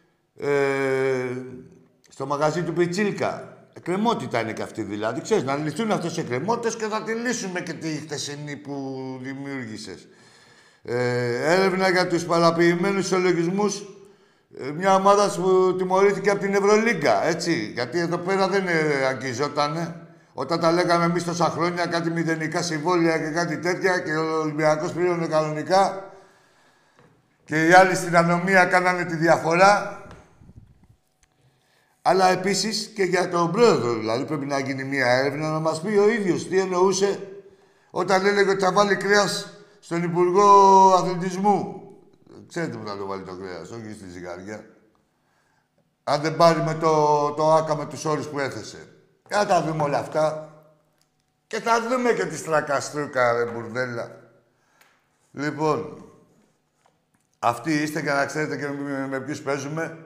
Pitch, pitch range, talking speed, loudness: 165 Hz, 145-190 Hz, 140 wpm, -22 LUFS